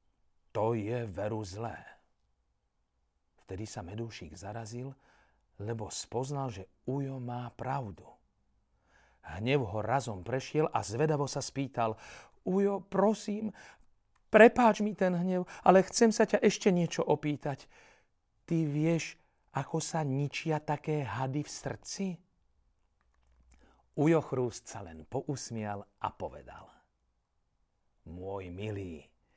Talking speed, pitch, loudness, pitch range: 110 wpm, 125 Hz, -32 LUFS, 100-155 Hz